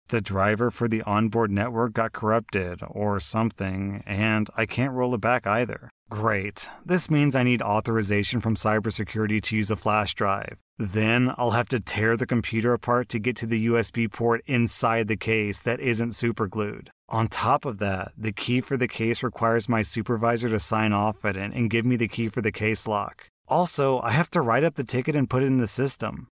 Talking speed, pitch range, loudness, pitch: 205 wpm, 110-125 Hz, -25 LUFS, 115 Hz